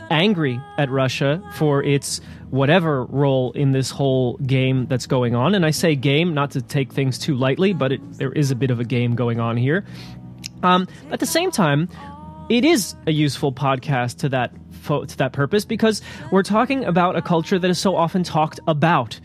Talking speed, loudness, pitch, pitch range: 200 wpm, -20 LUFS, 140 Hz, 130-175 Hz